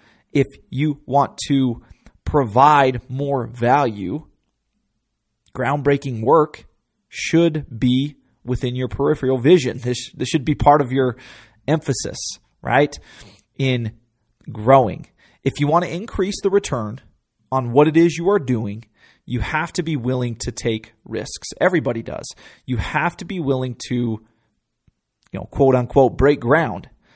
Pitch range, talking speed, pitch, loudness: 120-145 Hz, 135 wpm, 130 Hz, -19 LUFS